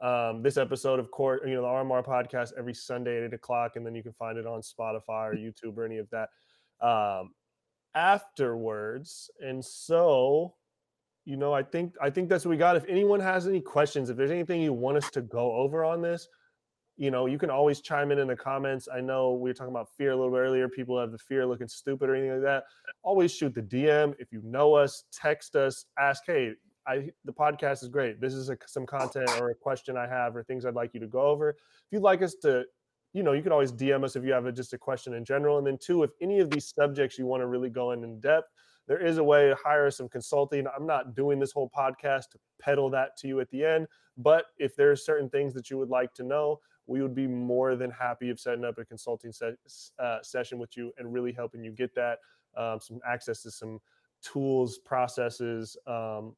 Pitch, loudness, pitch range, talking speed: 130 Hz, -29 LUFS, 120-145 Hz, 240 wpm